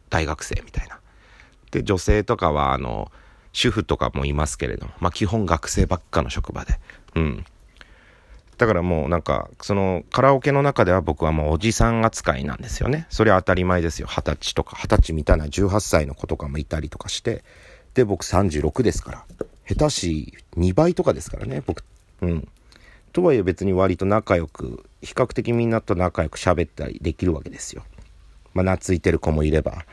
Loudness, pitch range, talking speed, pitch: -22 LUFS, 80-105 Hz, 350 characters per minute, 90 Hz